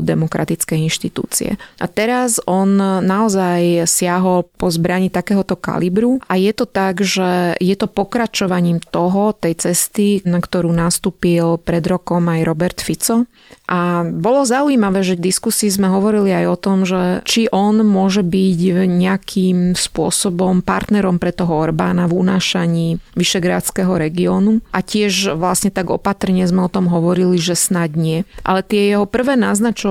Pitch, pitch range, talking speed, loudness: 185 Hz, 175-205 Hz, 145 wpm, -16 LUFS